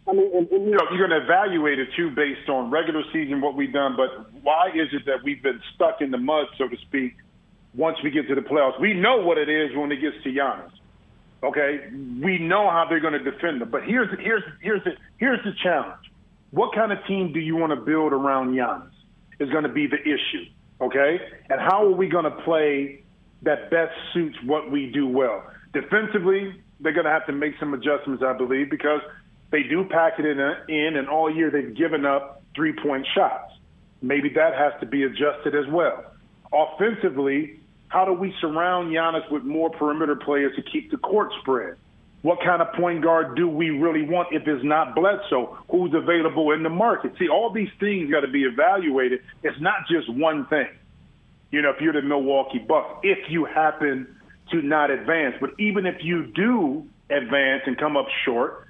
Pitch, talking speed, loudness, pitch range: 155 Hz, 205 wpm, -23 LUFS, 145-180 Hz